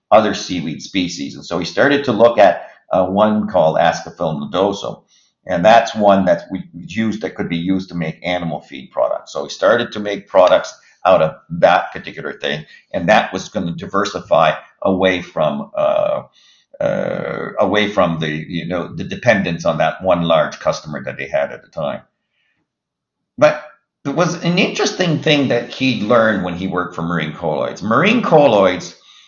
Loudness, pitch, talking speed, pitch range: -16 LUFS, 105 Hz, 180 wpm, 90-140 Hz